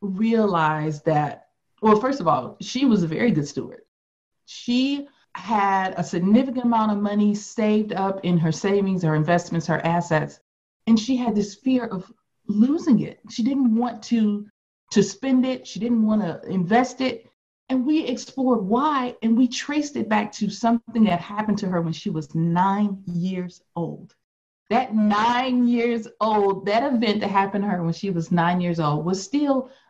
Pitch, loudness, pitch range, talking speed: 210 Hz, -22 LUFS, 185-240 Hz, 175 wpm